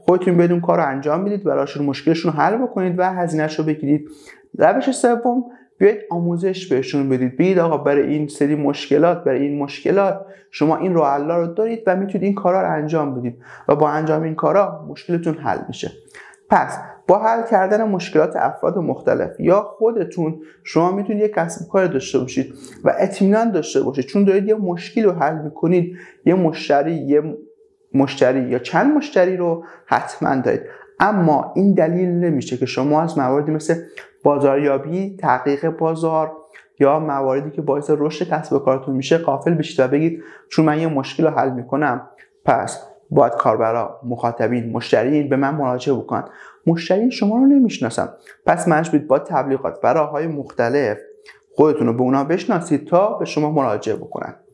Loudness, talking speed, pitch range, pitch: -18 LUFS, 165 wpm, 140-190 Hz, 160 Hz